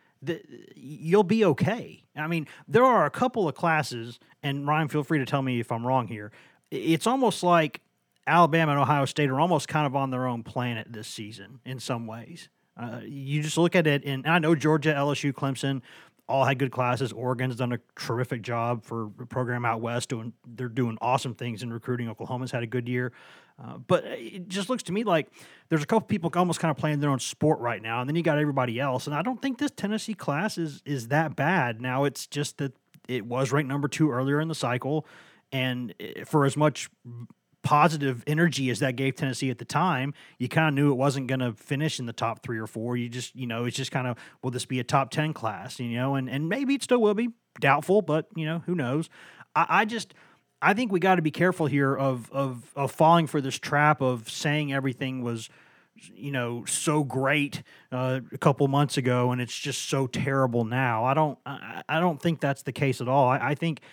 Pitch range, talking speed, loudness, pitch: 125-155 Hz, 230 wpm, -26 LUFS, 140 Hz